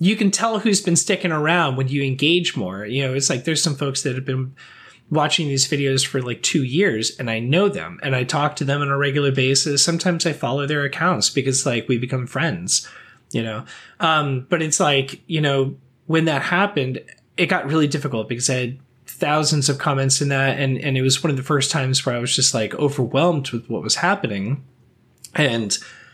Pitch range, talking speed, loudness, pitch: 130-160 Hz, 215 wpm, -20 LUFS, 140 Hz